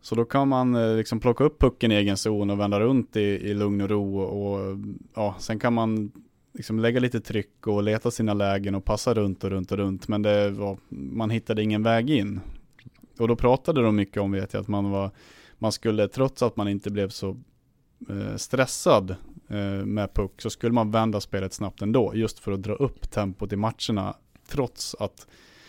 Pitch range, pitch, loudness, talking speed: 100-115 Hz, 105 Hz, -26 LUFS, 210 wpm